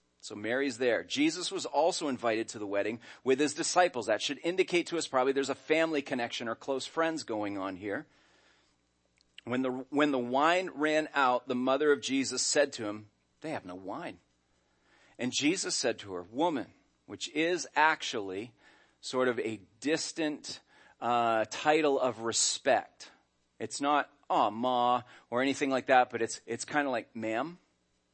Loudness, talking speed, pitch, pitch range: -31 LUFS, 170 wpm, 125 Hz, 110-150 Hz